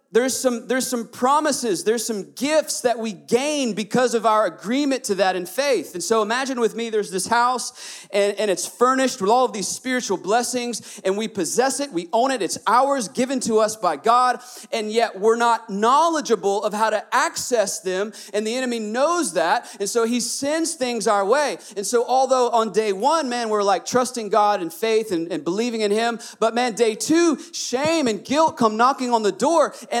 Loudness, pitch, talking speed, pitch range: -21 LUFS, 235 Hz, 210 wpm, 215-255 Hz